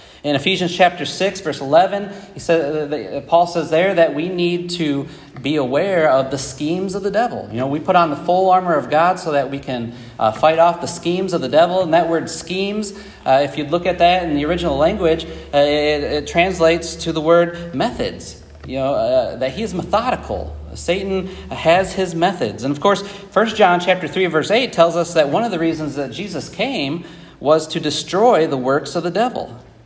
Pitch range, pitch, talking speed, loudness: 145-185 Hz, 170 Hz, 210 wpm, -18 LUFS